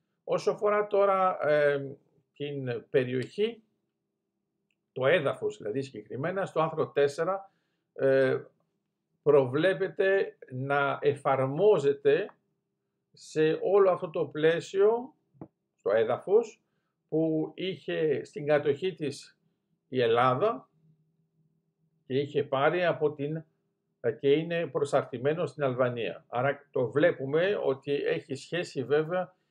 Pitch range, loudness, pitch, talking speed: 145-190 Hz, -28 LUFS, 160 Hz, 100 wpm